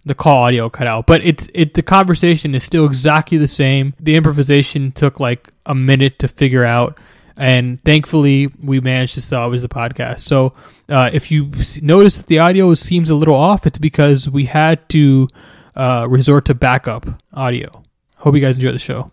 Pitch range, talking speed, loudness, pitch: 130-155 Hz, 190 wpm, -13 LUFS, 140 Hz